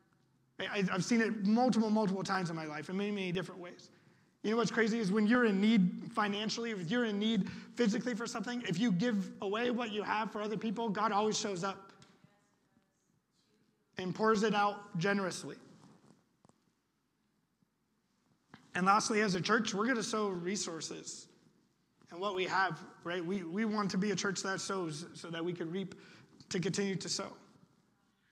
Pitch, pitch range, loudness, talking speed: 200 Hz, 185-220 Hz, -34 LUFS, 175 wpm